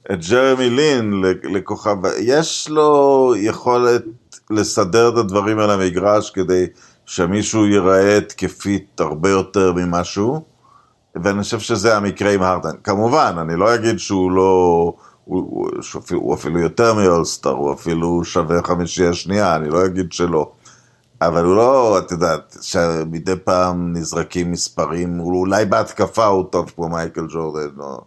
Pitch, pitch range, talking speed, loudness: 95 Hz, 85-105 Hz, 140 wpm, -17 LUFS